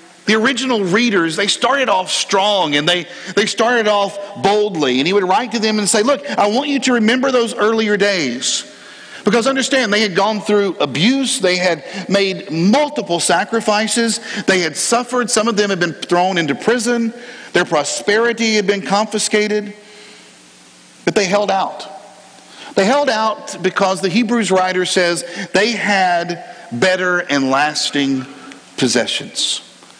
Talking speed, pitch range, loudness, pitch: 150 wpm, 180-225 Hz, -15 LUFS, 205 Hz